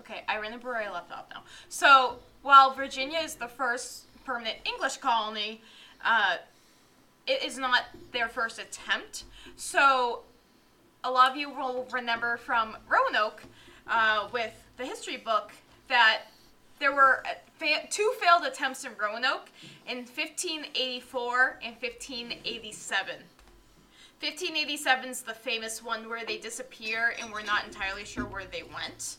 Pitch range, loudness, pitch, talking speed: 225-270 Hz, -27 LUFS, 250 Hz, 140 wpm